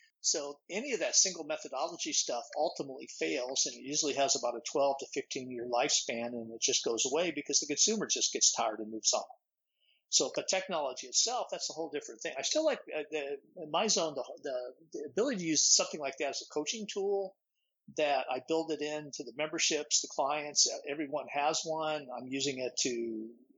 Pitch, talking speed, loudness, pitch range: 150 Hz, 200 wpm, -32 LUFS, 135-195 Hz